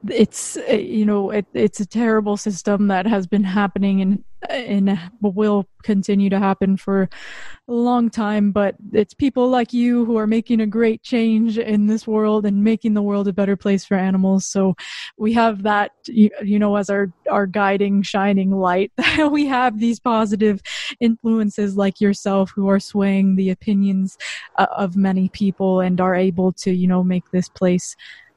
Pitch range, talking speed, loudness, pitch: 195-220 Hz, 175 wpm, -19 LUFS, 205 Hz